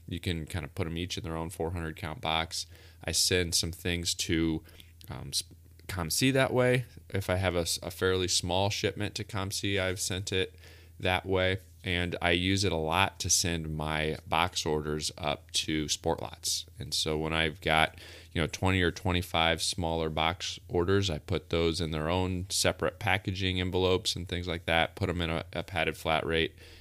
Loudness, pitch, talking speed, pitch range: -30 LUFS, 85 Hz, 190 wpm, 80-95 Hz